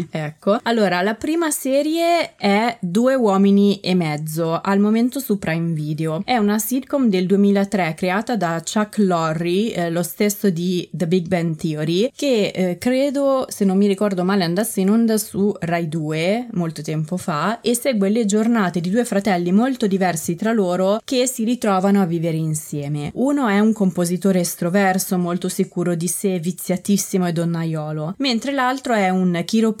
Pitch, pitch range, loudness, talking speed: 195 Hz, 175-225 Hz, -19 LUFS, 165 wpm